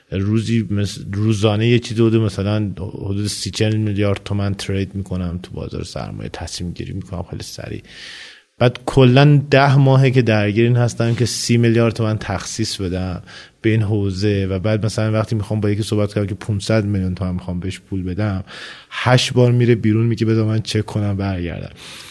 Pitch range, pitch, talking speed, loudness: 100-115 Hz, 105 Hz, 175 wpm, -18 LUFS